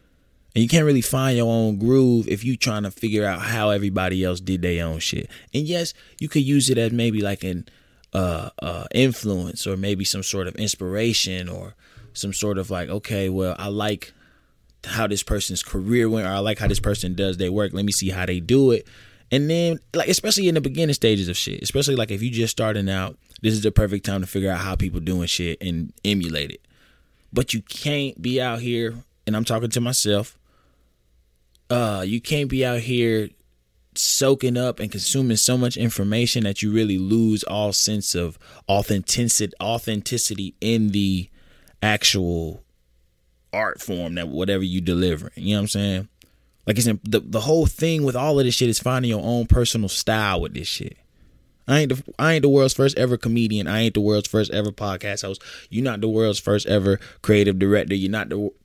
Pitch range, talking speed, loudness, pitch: 95-120 Hz, 205 wpm, -22 LUFS, 105 Hz